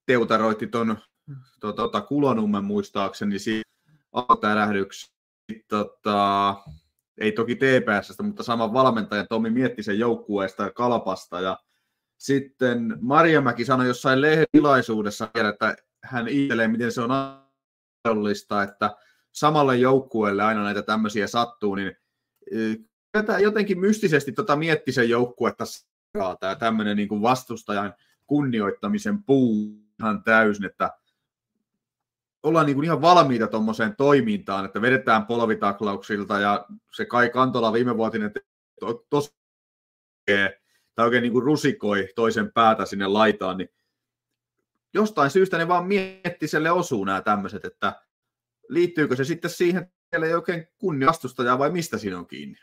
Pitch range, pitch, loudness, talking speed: 105-145 Hz, 115 Hz, -23 LUFS, 120 wpm